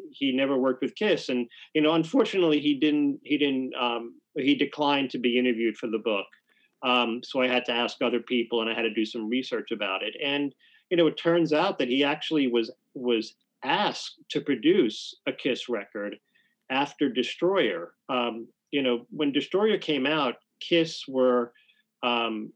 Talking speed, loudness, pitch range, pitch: 180 wpm, -26 LUFS, 120-155 Hz, 135 Hz